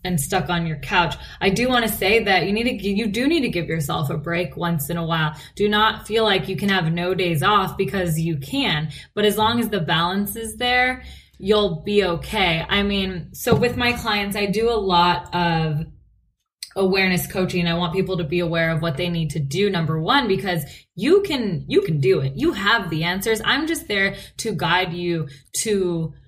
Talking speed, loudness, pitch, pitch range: 215 wpm, -21 LUFS, 185 Hz, 170-210 Hz